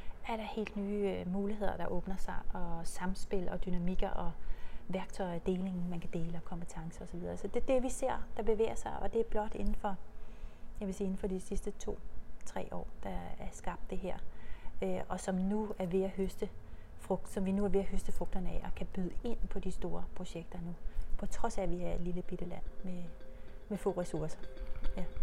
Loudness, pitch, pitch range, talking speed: -39 LUFS, 190 Hz, 180-205 Hz, 225 wpm